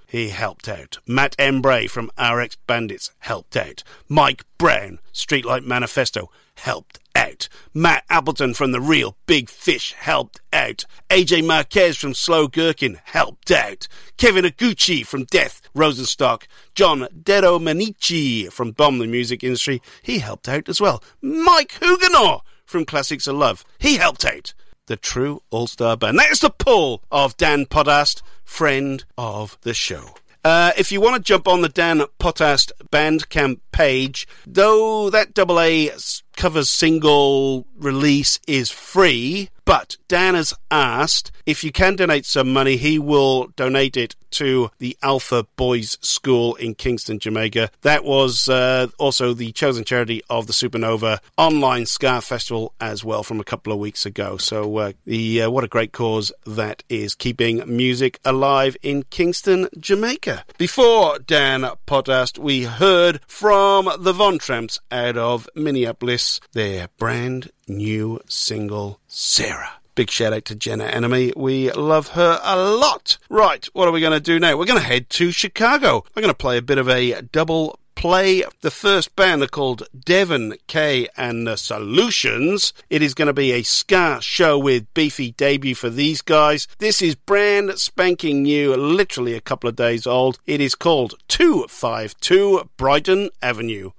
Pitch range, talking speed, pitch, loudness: 120-165 Hz, 155 wpm, 135 Hz, -18 LUFS